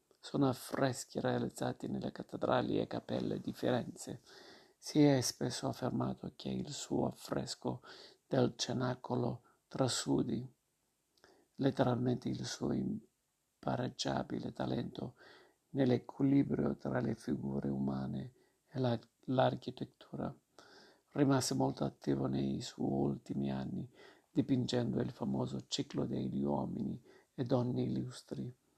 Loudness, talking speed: -37 LUFS, 100 wpm